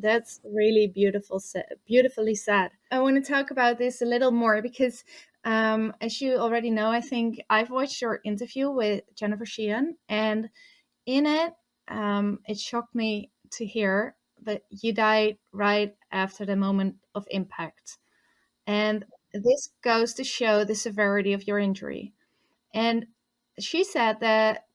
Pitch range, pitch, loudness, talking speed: 210-245 Hz, 220 Hz, -26 LUFS, 150 wpm